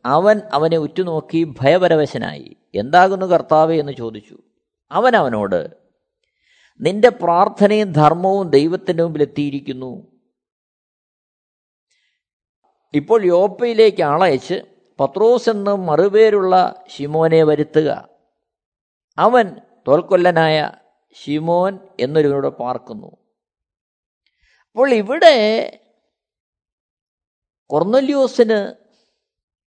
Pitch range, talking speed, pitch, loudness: 150-215 Hz, 65 wpm, 180 Hz, -16 LUFS